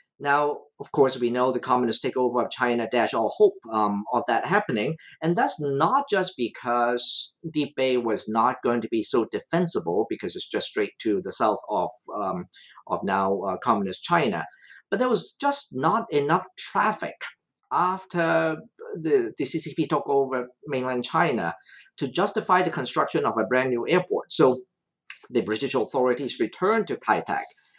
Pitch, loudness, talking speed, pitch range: 145 Hz, -24 LUFS, 165 wpm, 125-190 Hz